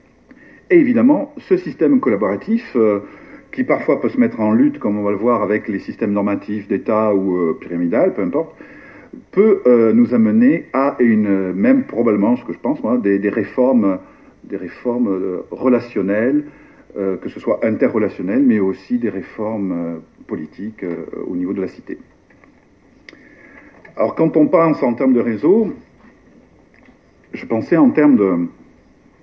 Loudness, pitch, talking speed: -17 LUFS, 125 Hz, 160 wpm